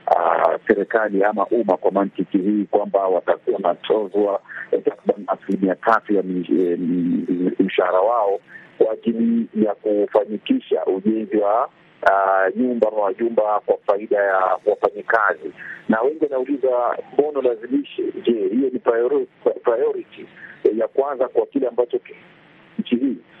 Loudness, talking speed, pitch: -20 LUFS, 150 wpm, 120 Hz